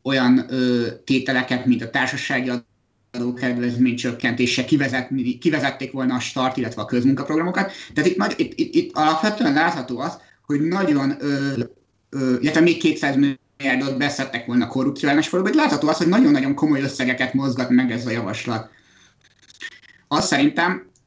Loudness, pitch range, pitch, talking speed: -20 LUFS, 125-145 Hz, 130 Hz, 140 wpm